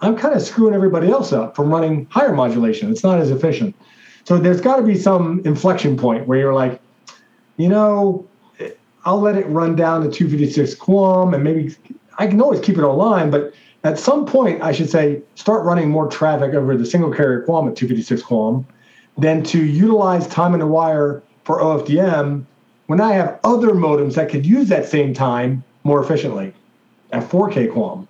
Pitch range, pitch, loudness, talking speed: 145-195 Hz, 160 Hz, -16 LUFS, 190 wpm